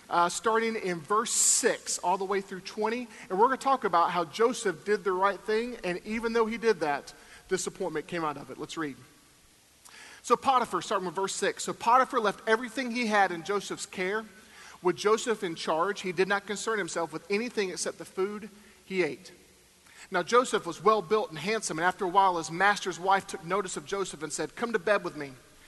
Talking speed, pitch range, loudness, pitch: 215 wpm, 180-220 Hz, -28 LUFS, 200 Hz